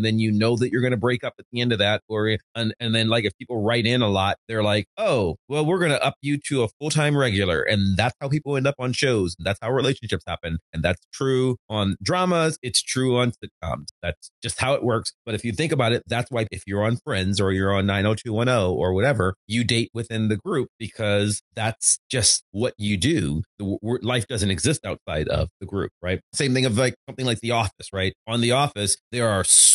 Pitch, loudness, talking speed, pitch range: 115 Hz, -23 LUFS, 245 wpm, 100-125 Hz